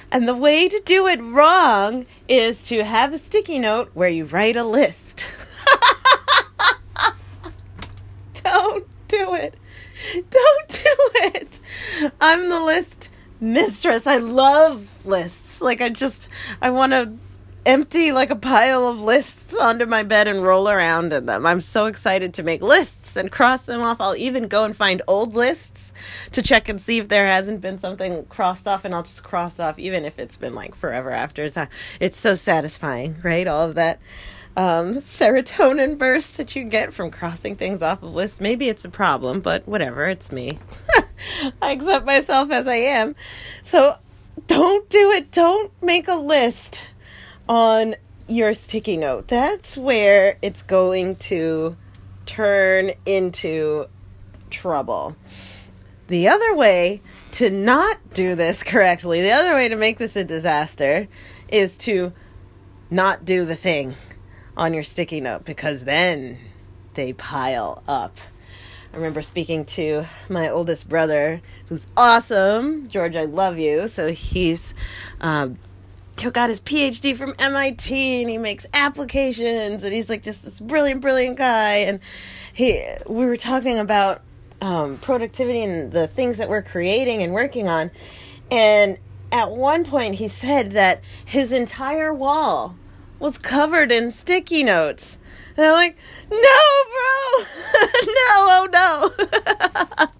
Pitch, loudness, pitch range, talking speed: 210 Hz, -18 LUFS, 160-270 Hz, 150 wpm